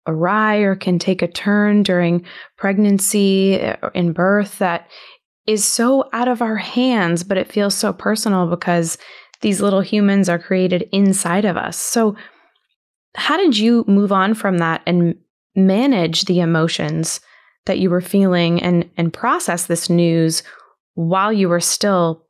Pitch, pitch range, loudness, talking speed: 190 Hz, 175-210 Hz, -17 LUFS, 155 wpm